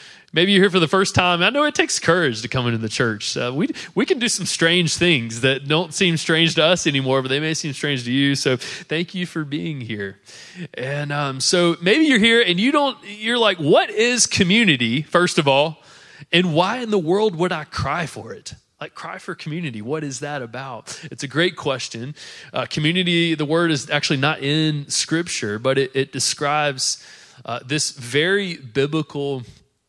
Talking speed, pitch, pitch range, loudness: 205 wpm, 155 Hz, 135-180 Hz, -19 LUFS